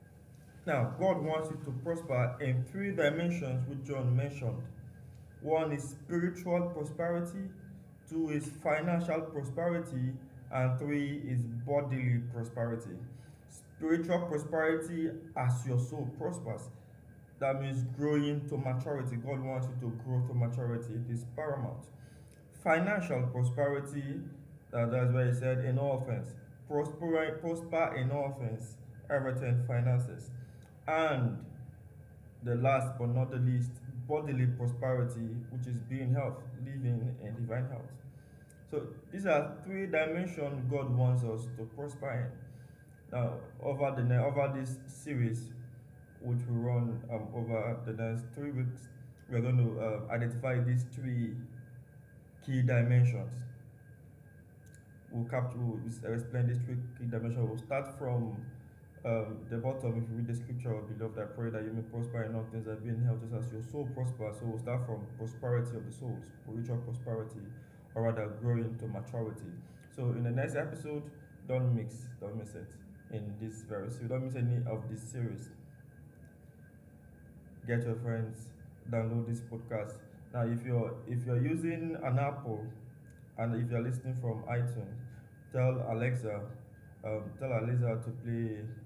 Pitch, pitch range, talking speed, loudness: 125 Hz, 115-140 Hz, 145 wpm, -35 LUFS